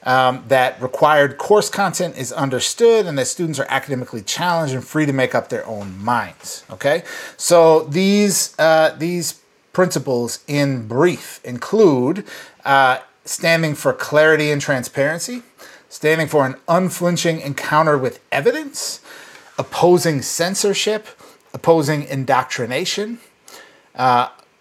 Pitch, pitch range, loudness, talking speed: 155 Hz, 135-175 Hz, -17 LUFS, 115 wpm